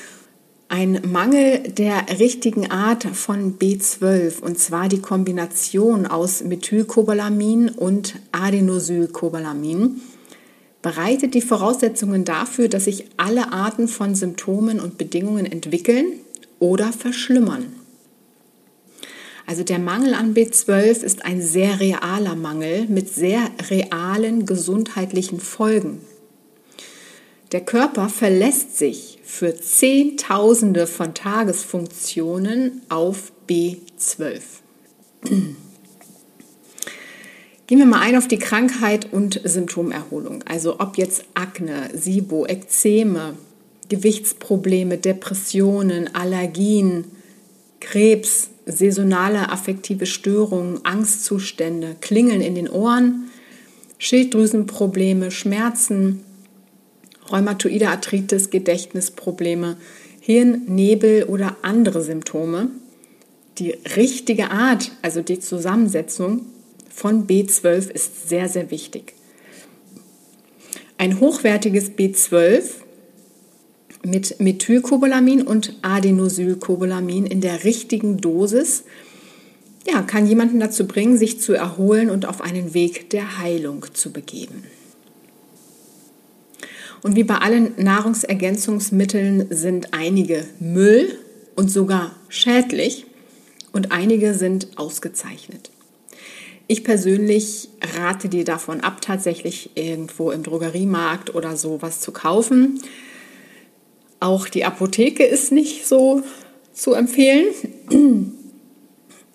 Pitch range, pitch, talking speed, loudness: 180-230 Hz, 200 Hz, 90 wpm, -18 LUFS